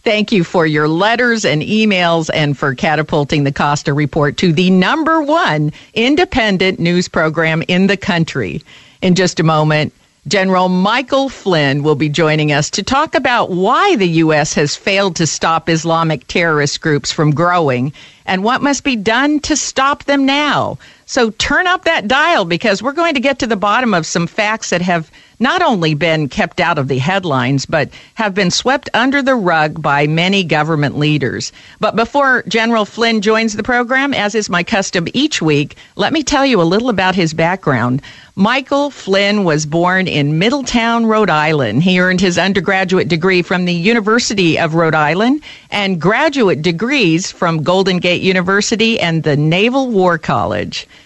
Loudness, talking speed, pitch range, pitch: -13 LUFS, 175 wpm, 155-225 Hz, 185 Hz